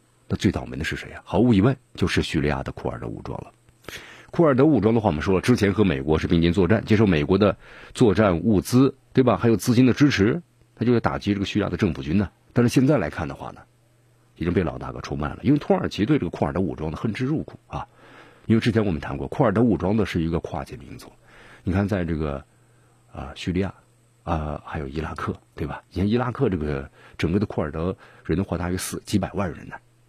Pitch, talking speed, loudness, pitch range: 105 Hz, 360 characters per minute, -23 LUFS, 85-120 Hz